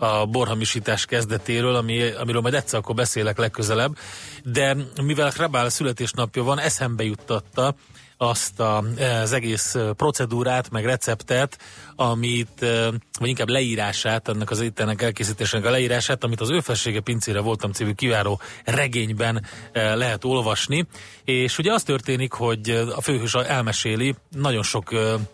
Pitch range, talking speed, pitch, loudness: 110-130 Hz, 130 wpm, 120 Hz, -23 LUFS